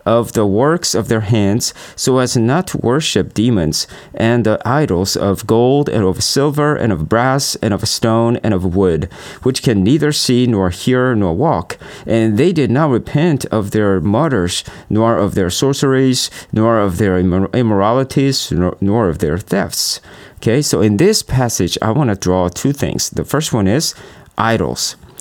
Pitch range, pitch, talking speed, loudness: 100-130 Hz, 115 Hz, 180 wpm, -15 LUFS